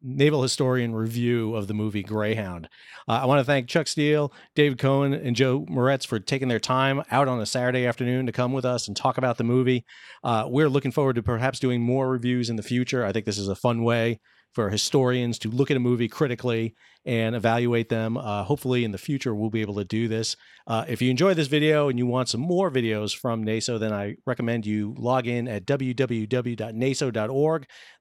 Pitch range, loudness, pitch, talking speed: 115-135 Hz, -25 LUFS, 125 Hz, 215 wpm